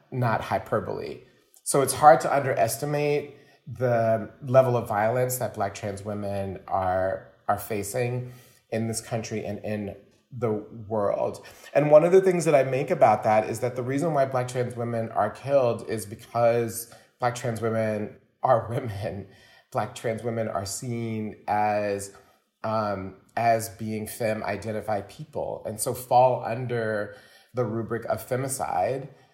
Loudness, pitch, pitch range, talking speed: -26 LUFS, 115 Hz, 105-125 Hz, 145 wpm